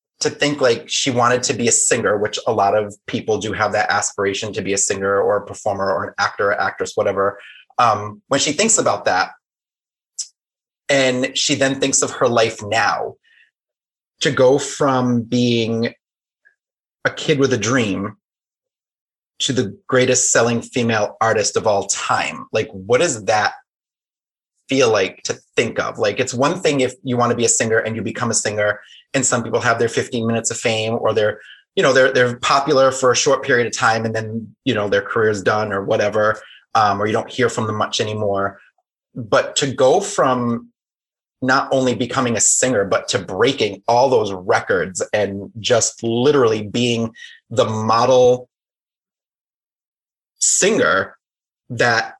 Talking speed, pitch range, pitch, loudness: 175 wpm, 110-130 Hz, 120 Hz, -18 LUFS